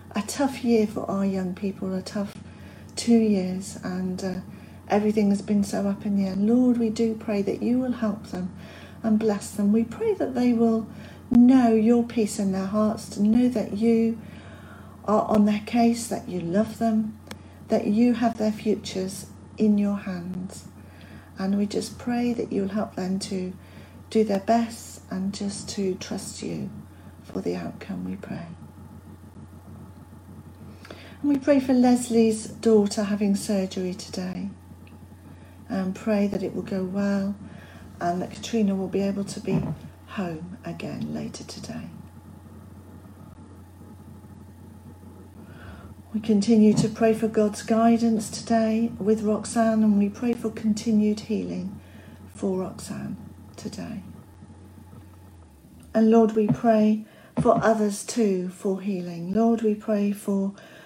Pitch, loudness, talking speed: 200 Hz, -24 LUFS, 145 wpm